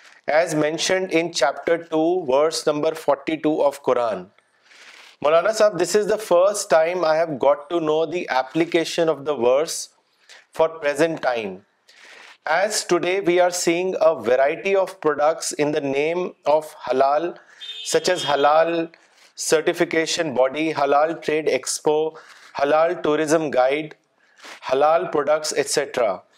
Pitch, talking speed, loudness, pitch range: 160 Hz, 135 wpm, -20 LUFS, 150-175 Hz